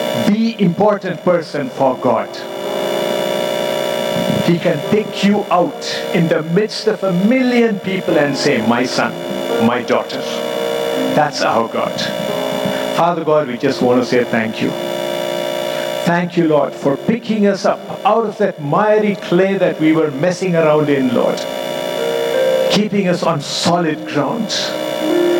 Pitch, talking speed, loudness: 155 Hz, 140 wpm, -16 LUFS